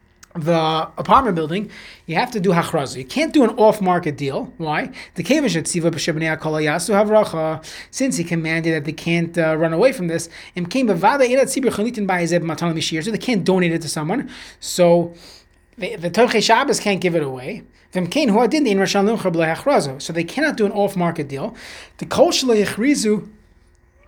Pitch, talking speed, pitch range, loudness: 175 Hz, 120 wpm, 160-215 Hz, -19 LUFS